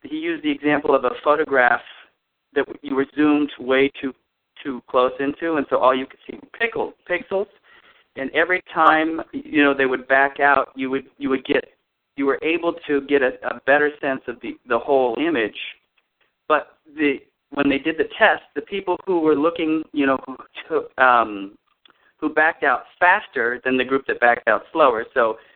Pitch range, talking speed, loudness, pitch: 135-170 Hz, 190 wpm, -20 LUFS, 145 Hz